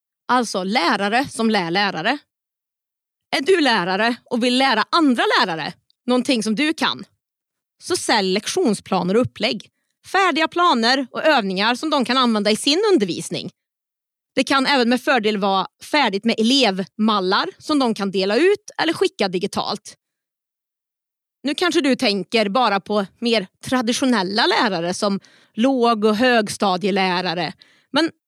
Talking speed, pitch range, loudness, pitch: 135 wpm, 200-280 Hz, -19 LUFS, 235 Hz